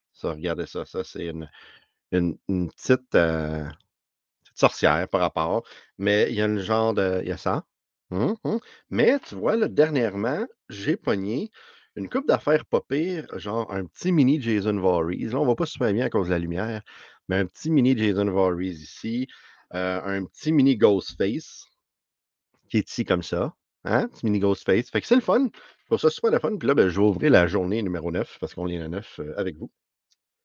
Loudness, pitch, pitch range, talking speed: -24 LUFS, 100 Hz, 90-120 Hz, 205 wpm